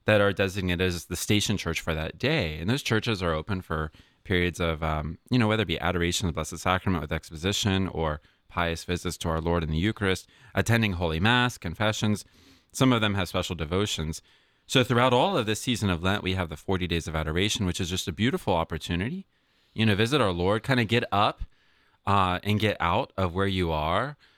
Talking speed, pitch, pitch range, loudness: 215 wpm, 95 Hz, 85-105 Hz, -26 LUFS